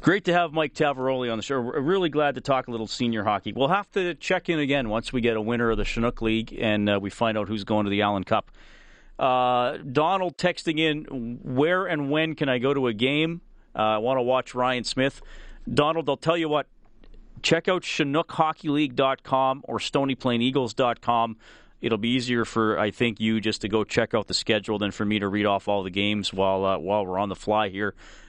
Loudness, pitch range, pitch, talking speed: -25 LUFS, 110-145 Hz, 125 Hz, 220 wpm